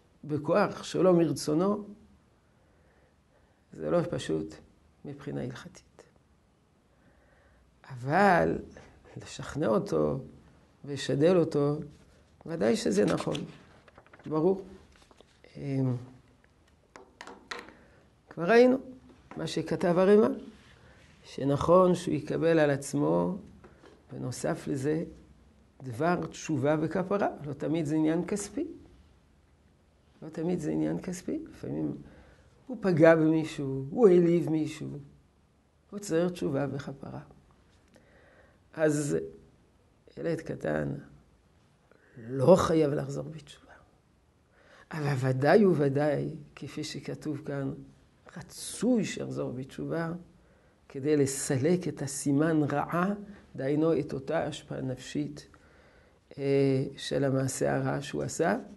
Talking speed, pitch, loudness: 85 wpm, 145 Hz, -29 LUFS